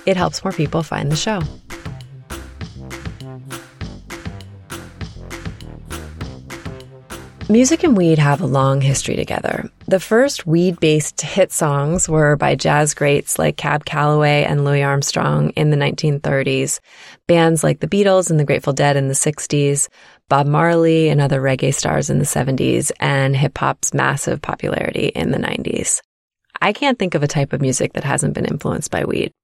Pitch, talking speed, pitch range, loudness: 145 Hz, 155 wpm, 130-165 Hz, -17 LUFS